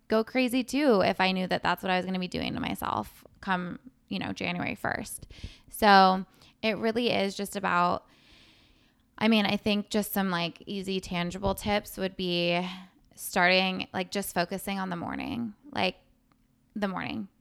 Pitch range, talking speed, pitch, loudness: 185-220 Hz, 170 wpm, 195 Hz, -28 LUFS